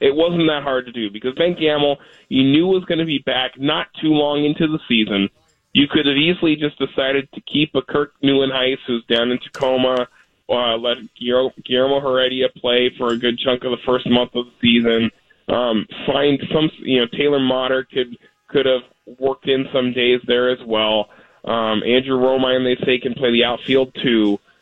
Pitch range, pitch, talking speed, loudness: 120-145 Hz, 130 Hz, 195 wpm, -18 LUFS